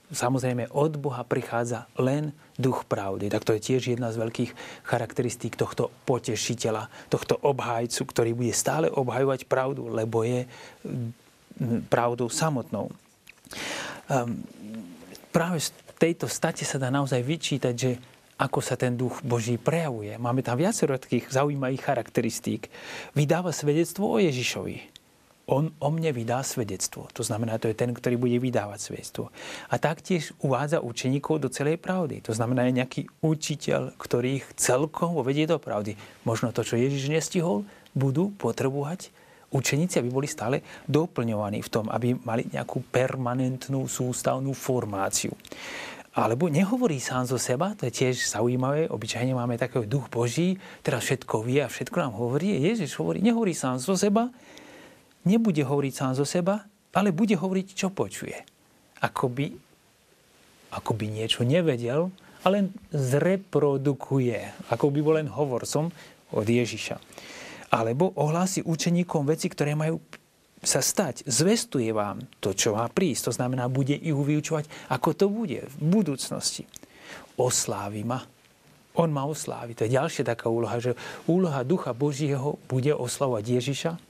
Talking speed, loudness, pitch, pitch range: 140 wpm, -27 LUFS, 135 Hz, 120-160 Hz